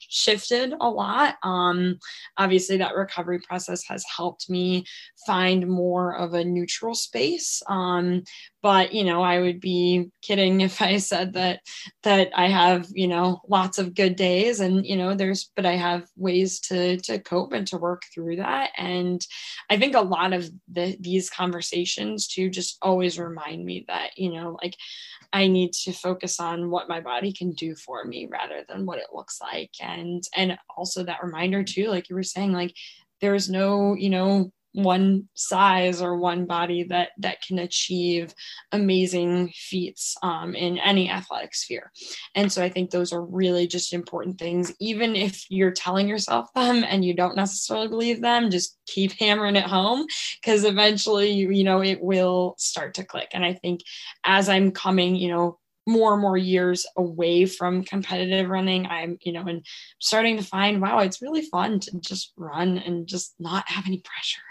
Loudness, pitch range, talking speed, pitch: -24 LUFS, 175-195 Hz, 180 wpm, 185 Hz